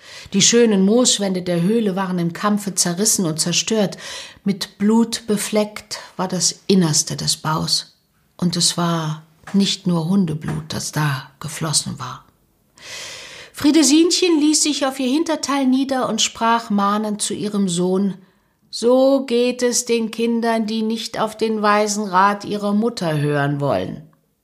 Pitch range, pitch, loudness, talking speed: 175-235 Hz, 205 Hz, -18 LUFS, 140 wpm